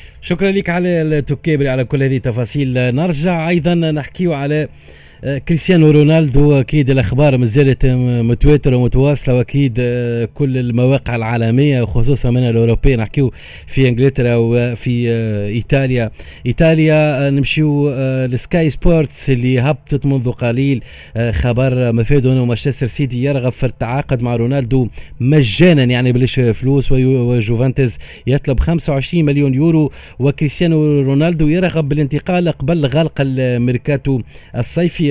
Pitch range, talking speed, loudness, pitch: 125-150 Hz, 115 wpm, -14 LUFS, 135 Hz